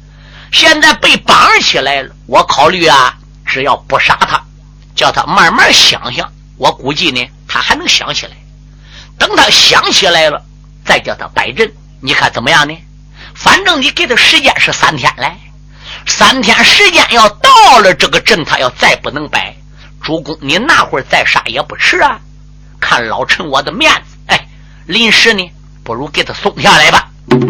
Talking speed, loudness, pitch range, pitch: 235 characters per minute, -8 LUFS, 145-225 Hz, 155 Hz